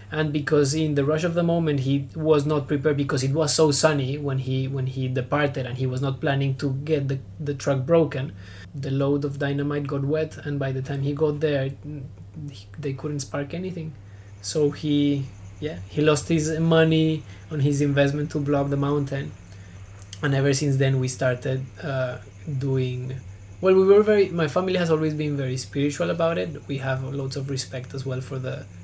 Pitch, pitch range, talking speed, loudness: 140 Hz, 130-150 Hz, 200 wpm, -24 LUFS